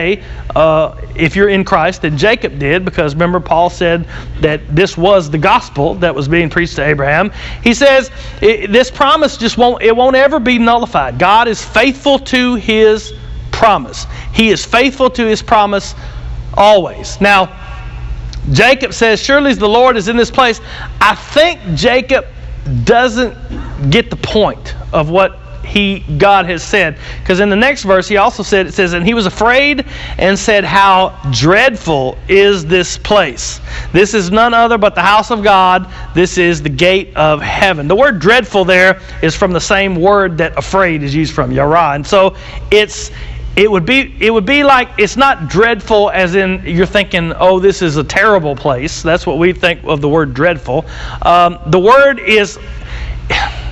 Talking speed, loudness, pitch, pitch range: 175 wpm, -11 LUFS, 190 Hz, 160-225 Hz